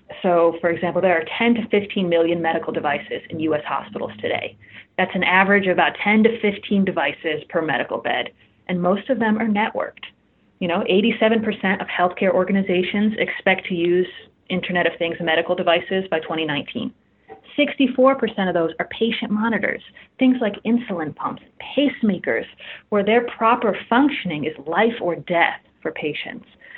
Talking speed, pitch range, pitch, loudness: 155 wpm, 175-225 Hz, 190 Hz, -20 LUFS